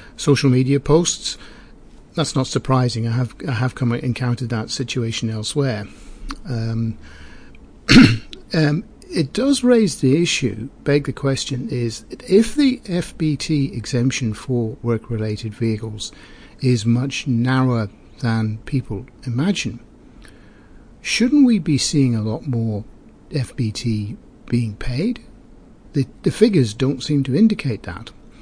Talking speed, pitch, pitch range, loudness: 120 wpm, 125 Hz, 115-145 Hz, -20 LUFS